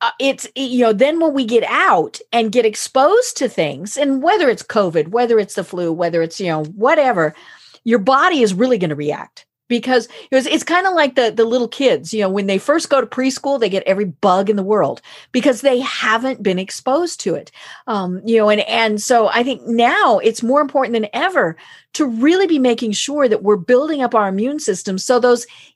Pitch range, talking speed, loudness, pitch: 210-275 Hz, 225 wpm, -16 LUFS, 240 Hz